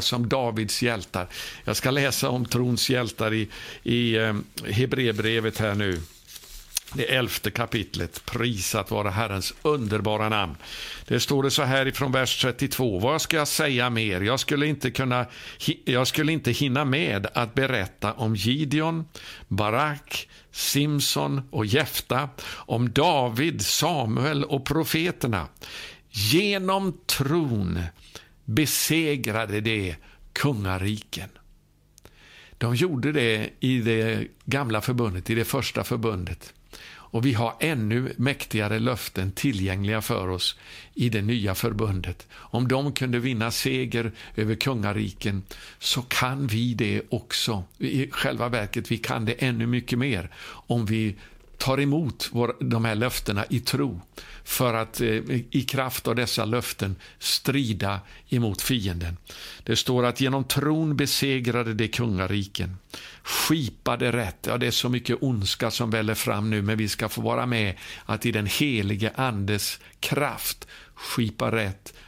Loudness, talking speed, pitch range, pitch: -25 LUFS, 135 wpm, 105-135 Hz, 120 Hz